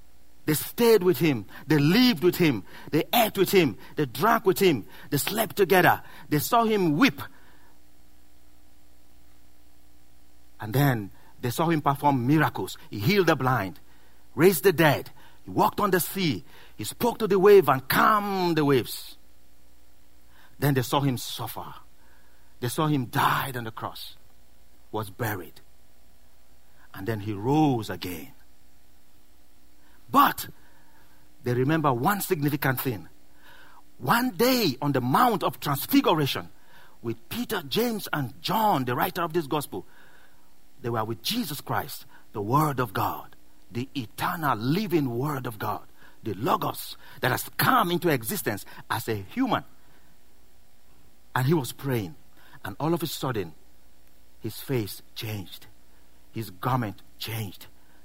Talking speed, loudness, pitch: 135 wpm, -25 LUFS, 120 Hz